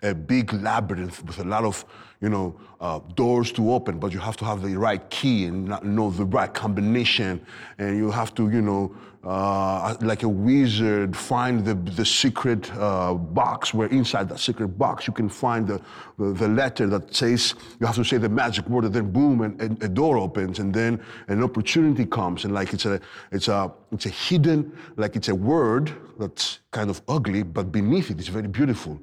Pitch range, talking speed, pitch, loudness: 100-120 Hz, 205 wpm, 110 Hz, -24 LUFS